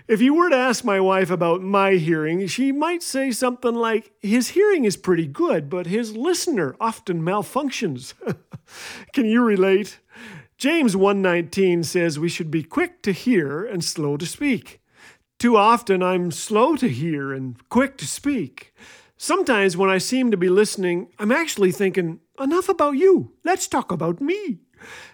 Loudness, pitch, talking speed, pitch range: -21 LUFS, 205 Hz, 160 wpm, 180-265 Hz